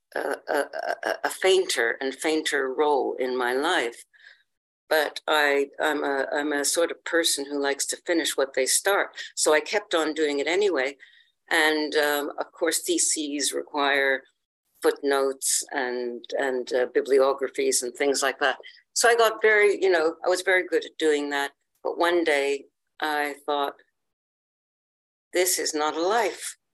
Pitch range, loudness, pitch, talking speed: 140-175 Hz, -24 LUFS, 150 Hz, 160 wpm